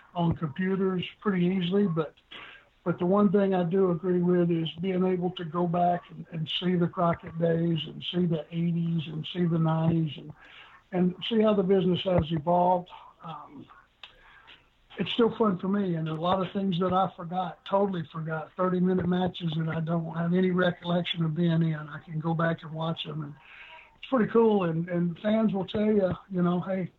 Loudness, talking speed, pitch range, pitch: -27 LUFS, 200 wpm, 165-185 Hz, 175 Hz